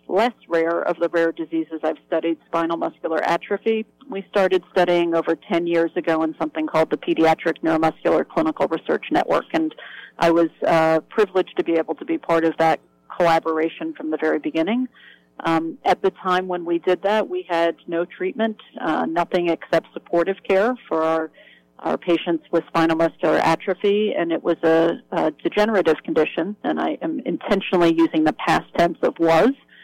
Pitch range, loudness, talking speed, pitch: 160-185 Hz, -21 LUFS, 175 wpm, 170 Hz